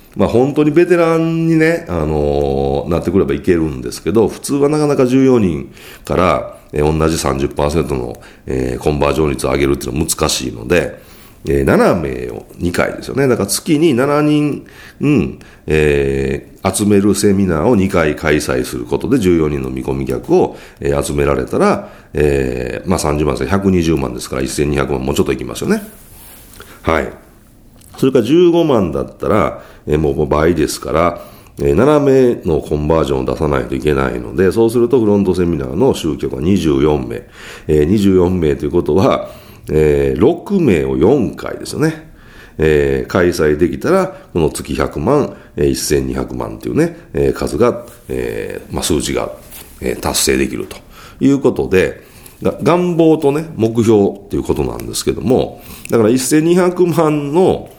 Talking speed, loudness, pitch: 290 characters per minute, -15 LUFS, 80 Hz